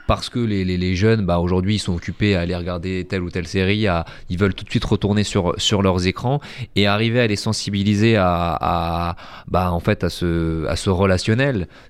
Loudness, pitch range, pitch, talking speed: -20 LUFS, 90-105 Hz, 95 Hz, 220 wpm